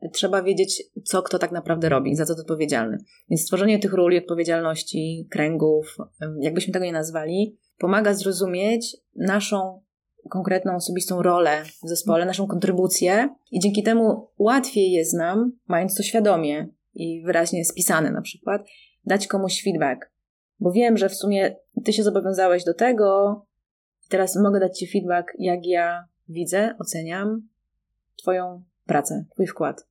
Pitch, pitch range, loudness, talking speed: 185 Hz, 170-205 Hz, -22 LUFS, 140 wpm